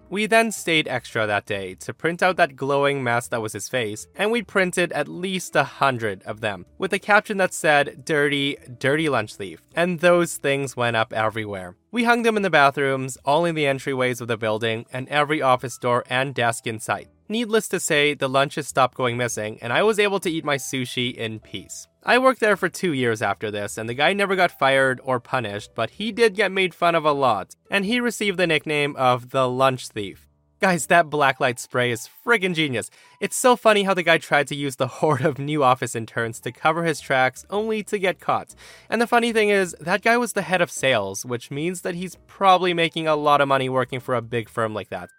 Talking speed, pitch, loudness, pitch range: 230 wpm, 140 Hz, -21 LUFS, 120-185 Hz